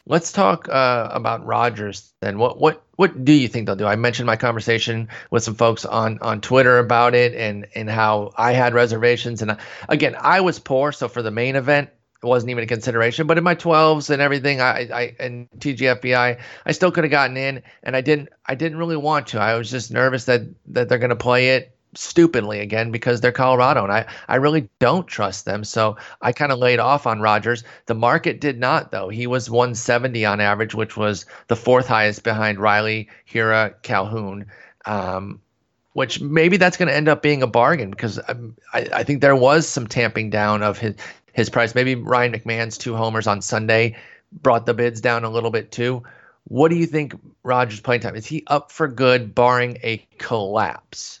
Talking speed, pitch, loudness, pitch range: 205 wpm, 120 Hz, -19 LUFS, 110-130 Hz